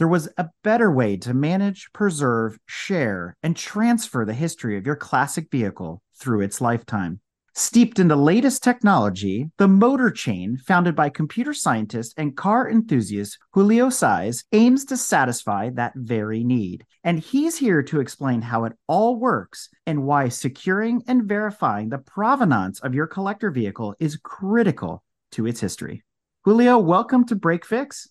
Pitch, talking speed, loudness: 160 Hz, 155 wpm, -21 LUFS